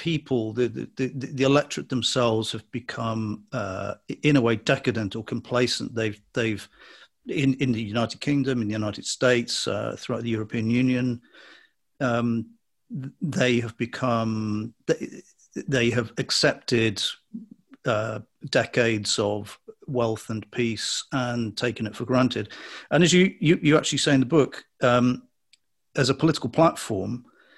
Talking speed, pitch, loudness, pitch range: 145 wpm, 120 Hz, -25 LUFS, 110-135 Hz